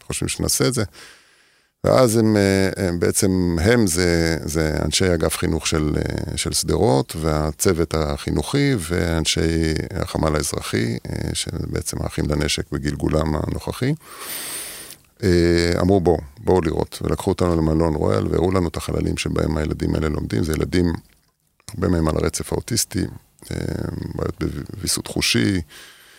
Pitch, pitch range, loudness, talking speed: 85 Hz, 80-95 Hz, -21 LUFS, 120 wpm